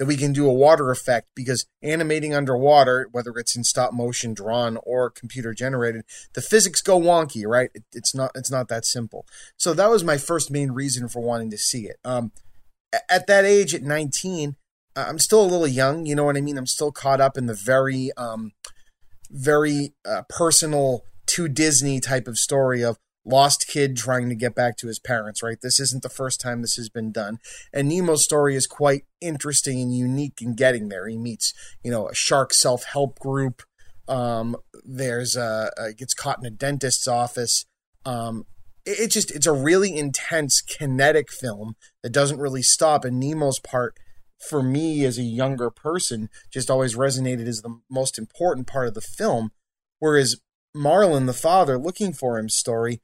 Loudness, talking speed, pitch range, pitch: -21 LUFS, 190 wpm, 120-145 Hz, 130 Hz